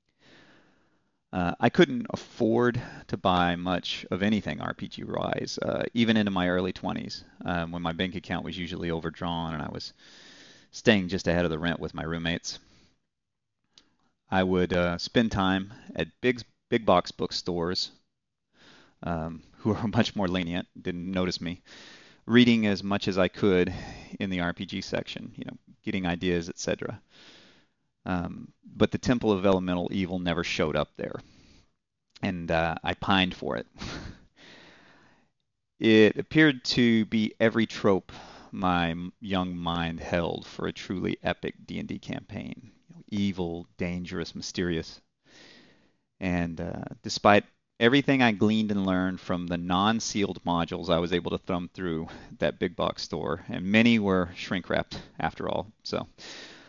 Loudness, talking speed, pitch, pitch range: -28 LUFS, 145 wpm, 90 Hz, 85-105 Hz